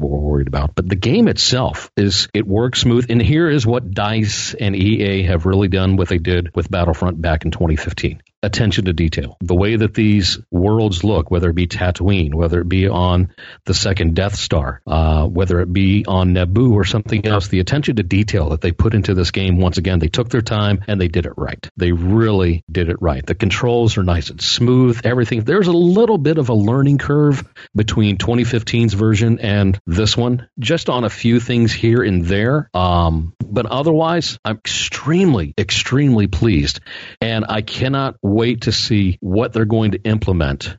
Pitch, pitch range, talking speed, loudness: 100 Hz, 90-115 Hz, 195 wpm, -16 LUFS